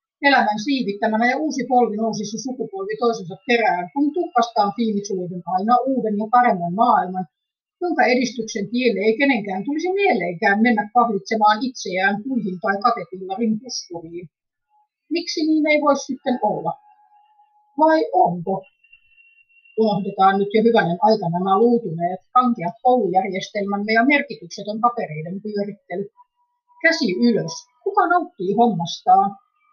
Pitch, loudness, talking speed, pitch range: 230 Hz, -20 LUFS, 115 wpm, 200-280 Hz